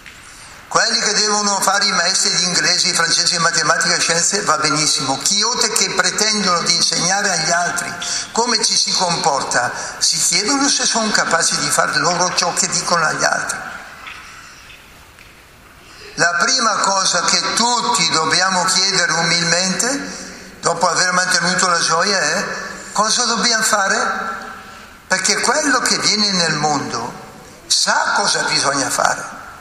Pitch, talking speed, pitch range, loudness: 190 Hz, 135 wpm, 170-210 Hz, -15 LUFS